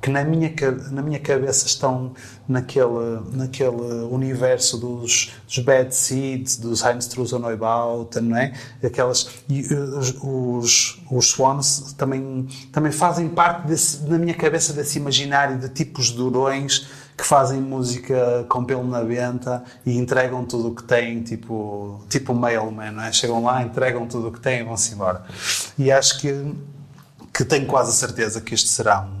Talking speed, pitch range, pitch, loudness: 165 wpm, 120-135 Hz, 130 Hz, -20 LUFS